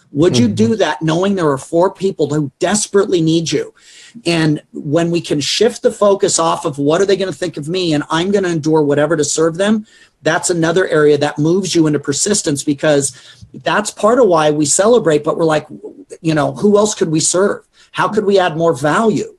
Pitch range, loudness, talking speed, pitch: 150-195 Hz, -14 LUFS, 215 wpm, 165 Hz